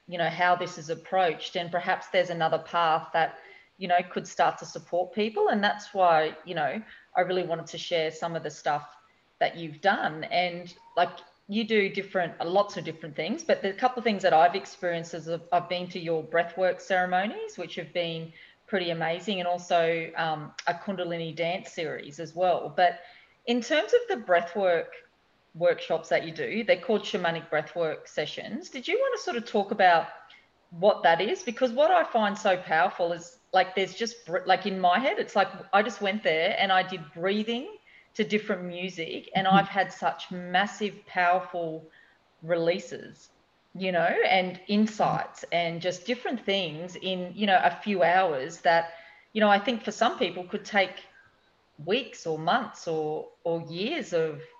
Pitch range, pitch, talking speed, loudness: 170-205 Hz, 180 Hz, 185 wpm, -27 LUFS